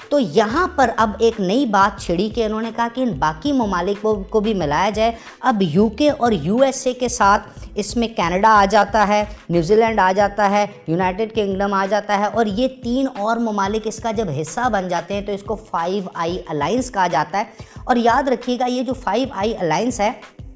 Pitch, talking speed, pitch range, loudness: 215 Hz, 220 wpm, 200-235 Hz, -19 LUFS